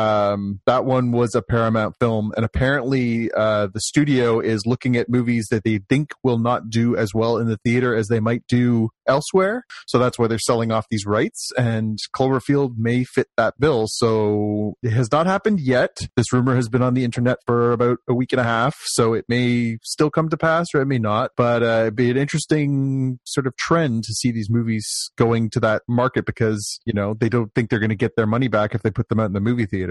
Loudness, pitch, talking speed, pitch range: -20 LUFS, 120 Hz, 235 wpm, 110-130 Hz